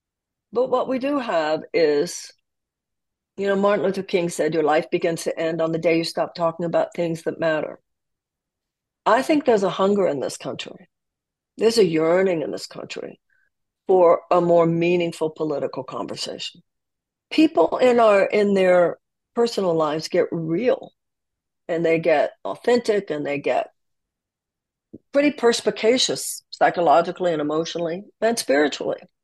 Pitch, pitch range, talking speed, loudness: 180 Hz, 165-225 Hz, 145 wpm, -21 LUFS